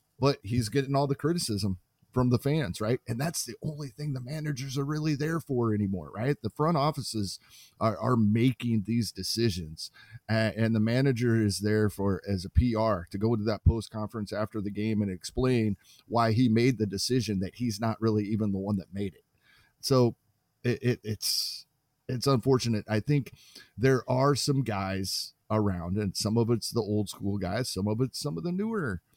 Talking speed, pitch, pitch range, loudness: 195 wpm, 115 Hz, 105-135 Hz, -29 LUFS